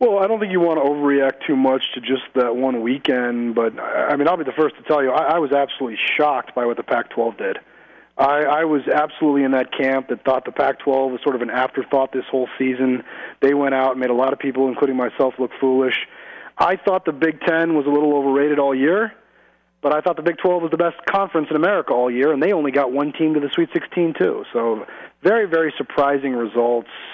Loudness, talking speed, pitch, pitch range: -19 LUFS, 240 wpm, 140 Hz, 130-155 Hz